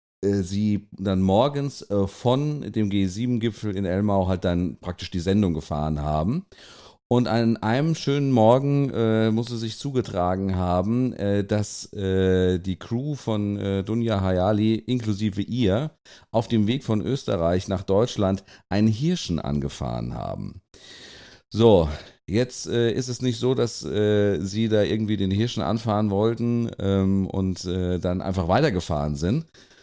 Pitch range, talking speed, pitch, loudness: 95-115 Hz, 145 wpm, 105 Hz, -24 LUFS